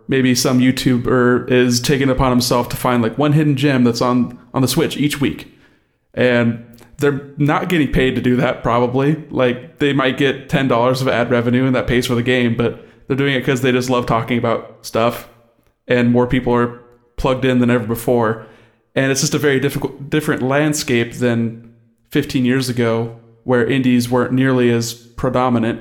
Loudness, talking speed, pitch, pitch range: -16 LUFS, 195 wpm, 125 Hz, 120-135 Hz